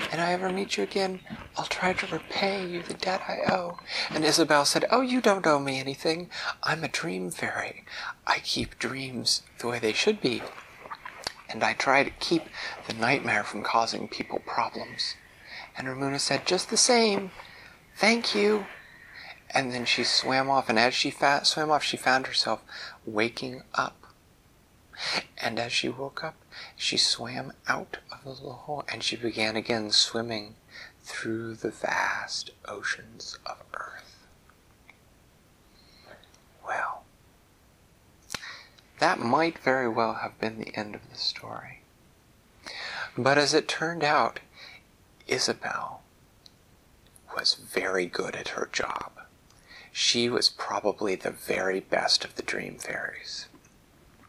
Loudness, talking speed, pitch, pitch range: -27 LUFS, 140 wpm, 135 Hz, 115-170 Hz